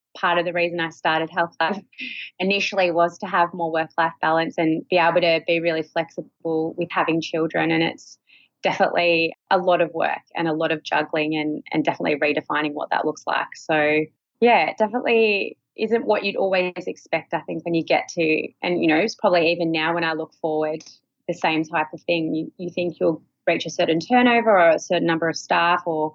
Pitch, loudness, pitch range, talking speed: 165 Hz, -21 LUFS, 160-175 Hz, 210 wpm